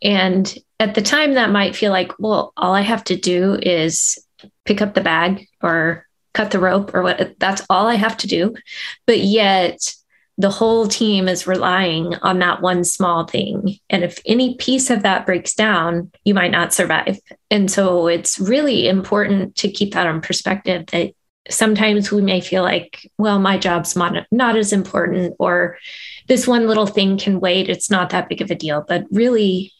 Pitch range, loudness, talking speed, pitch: 180-215 Hz, -17 LUFS, 185 wpm, 195 Hz